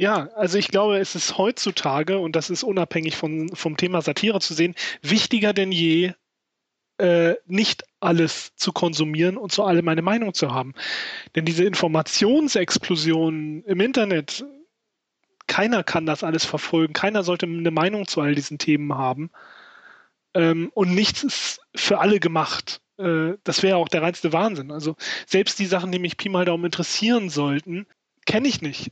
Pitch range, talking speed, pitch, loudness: 160-195 Hz, 165 wpm, 175 Hz, -22 LUFS